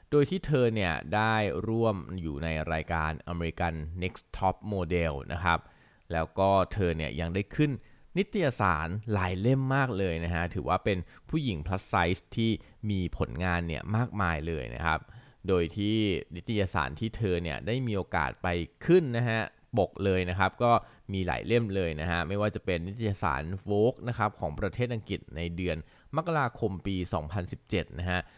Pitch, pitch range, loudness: 95 Hz, 85-110 Hz, -30 LUFS